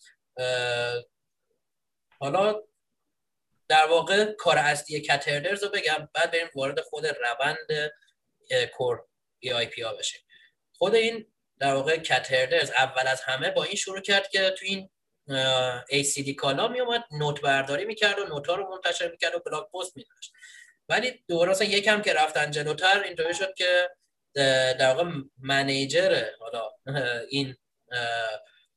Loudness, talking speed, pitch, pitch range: -26 LUFS, 135 wpm, 165 Hz, 135-200 Hz